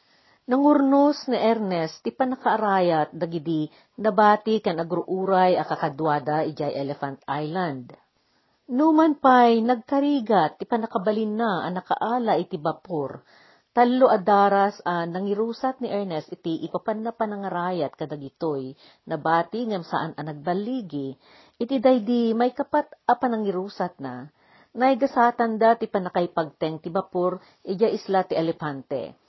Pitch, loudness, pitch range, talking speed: 195 Hz, -23 LUFS, 160-230 Hz, 115 wpm